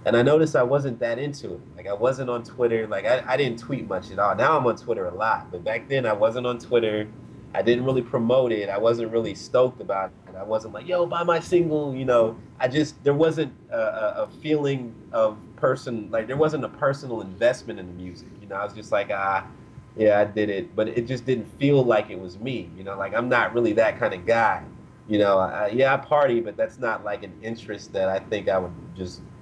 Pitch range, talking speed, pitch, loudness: 105-140 Hz, 245 wpm, 120 Hz, -24 LUFS